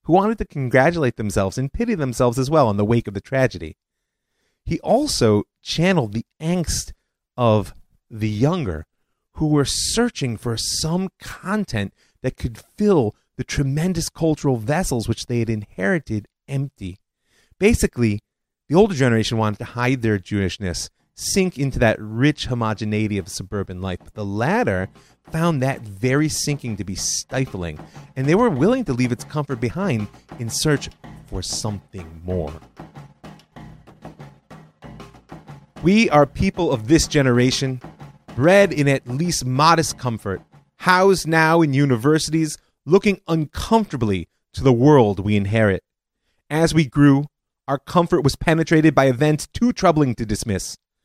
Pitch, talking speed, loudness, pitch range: 130 Hz, 140 wpm, -20 LUFS, 110-160 Hz